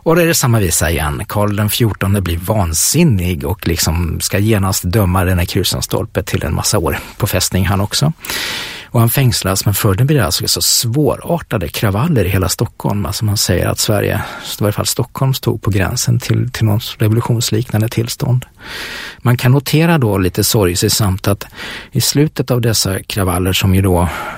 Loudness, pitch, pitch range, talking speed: -14 LUFS, 110 Hz, 95-120 Hz, 190 wpm